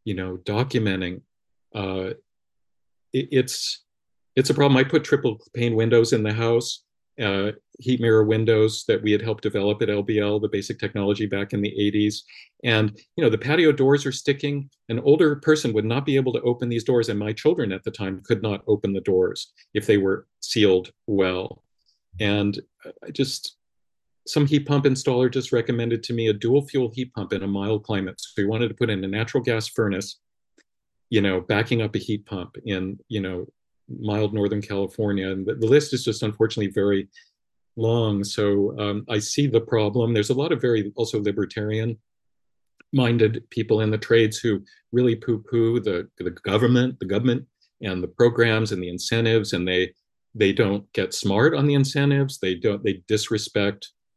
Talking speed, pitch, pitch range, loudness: 185 wpm, 110 Hz, 100-120 Hz, -23 LUFS